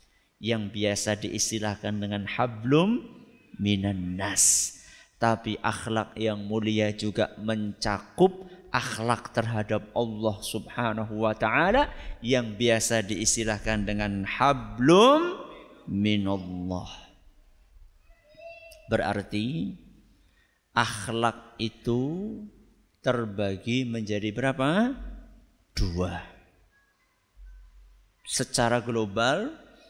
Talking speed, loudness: 65 wpm, -27 LUFS